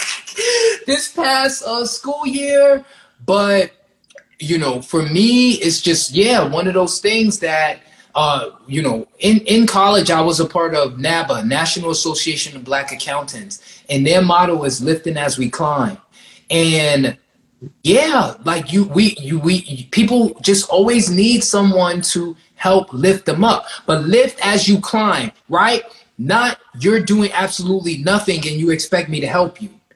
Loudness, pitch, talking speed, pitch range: -15 LUFS, 185 Hz, 155 wpm, 165-220 Hz